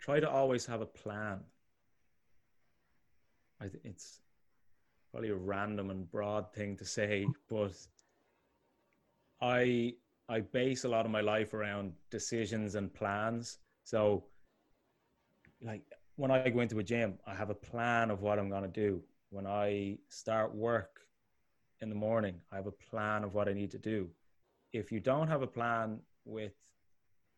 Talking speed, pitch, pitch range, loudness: 155 wpm, 105 Hz, 100-115 Hz, -36 LUFS